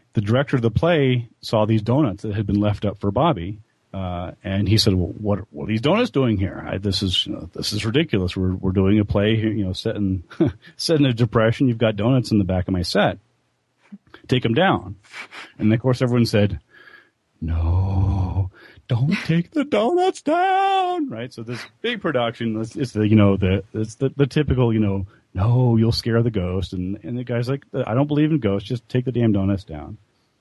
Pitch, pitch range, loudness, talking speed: 110 Hz, 100-130 Hz, -21 LUFS, 215 wpm